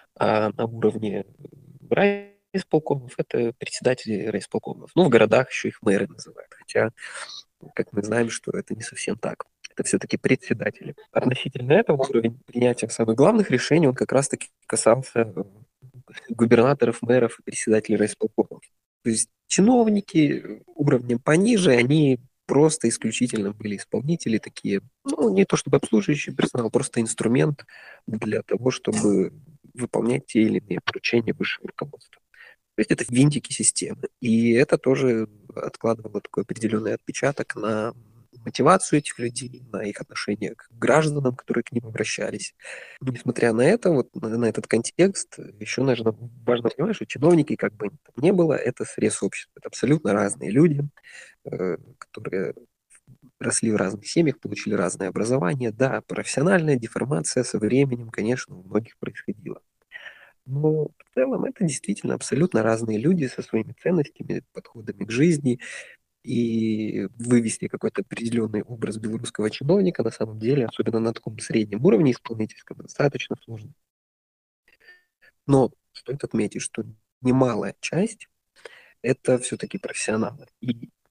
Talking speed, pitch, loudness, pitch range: 135 wpm, 120 Hz, -23 LUFS, 110-145 Hz